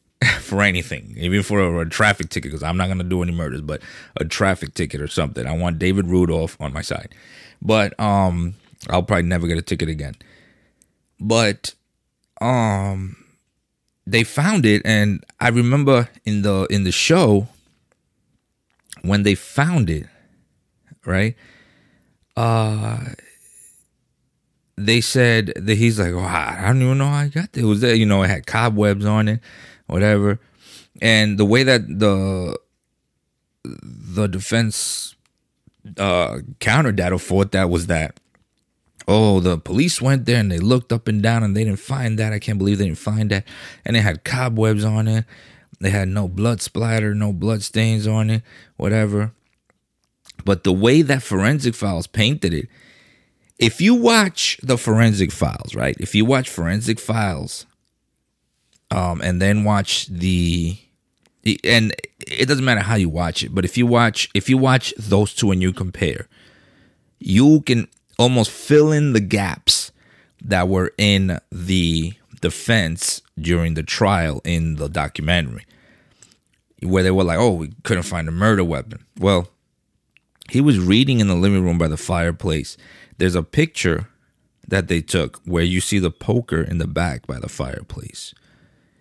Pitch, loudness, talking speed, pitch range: 100 Hz, -19 LUFS, 160 wpm, 90-115 Hz